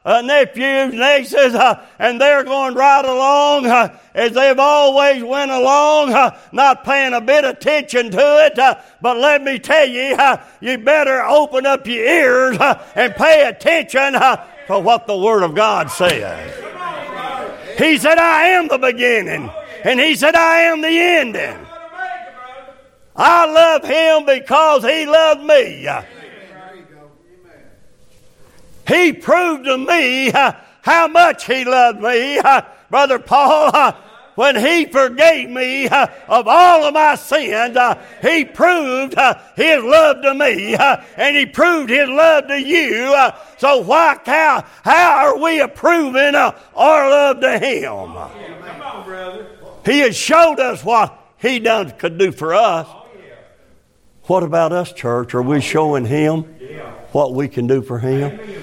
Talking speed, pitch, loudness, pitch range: 150 wpm, 275 Hz, -13 LUFS, 245-305 Hz